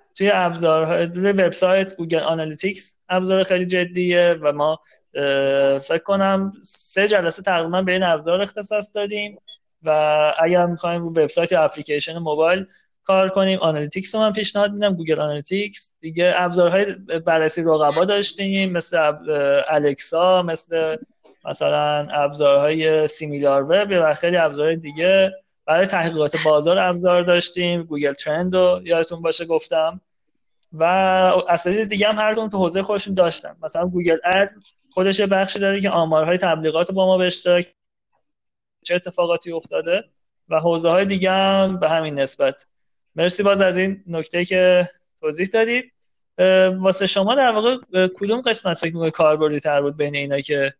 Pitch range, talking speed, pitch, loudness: 160-195 Hz, 140 wpm, 175 Hz, -19 LUFS